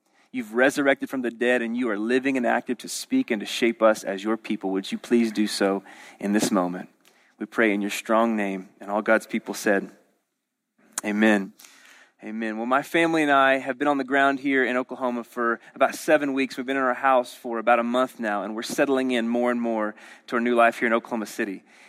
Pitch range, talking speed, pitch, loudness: 110-130 Hz, 230 wpm, 120 Hz, -24 LUFS